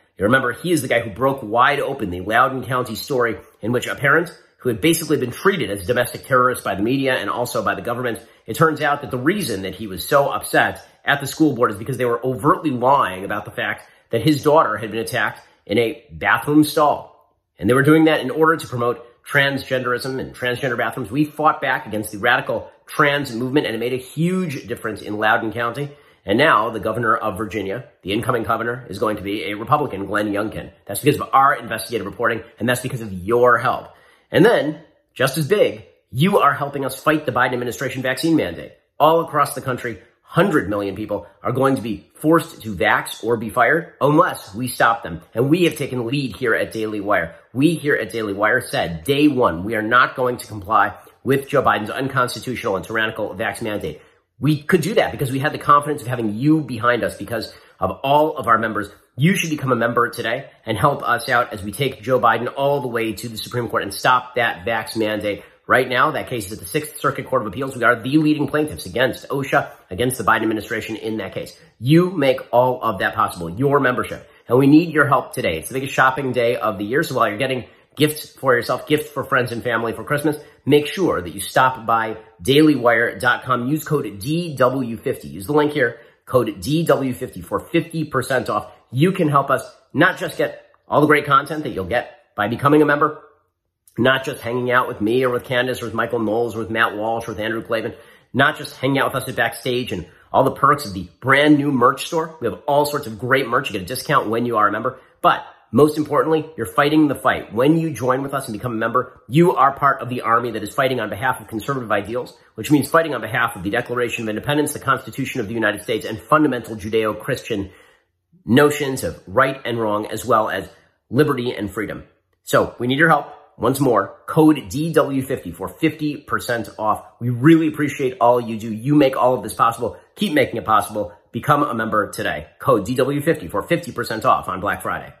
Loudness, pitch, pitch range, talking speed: -19 LUFS, 125 Hz, 110-145 Hz, 220 wpm